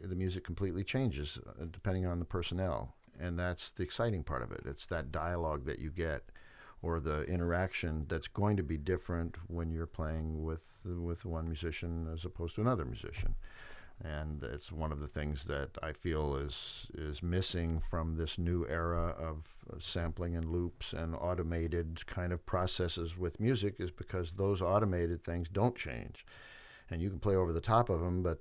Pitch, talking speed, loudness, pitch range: 85 Hz, 180 wpm, -37 LUFS, 80-90 Hz